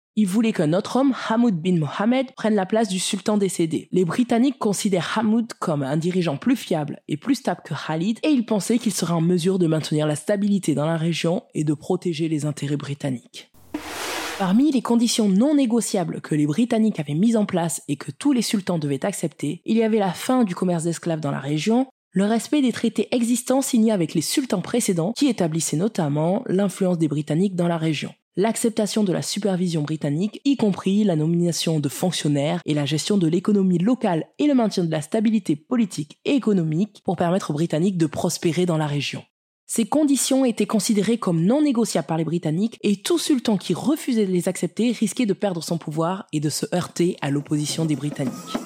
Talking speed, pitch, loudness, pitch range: 200 wpm, 190 Hz, -22 LUFS, 160-225 Hz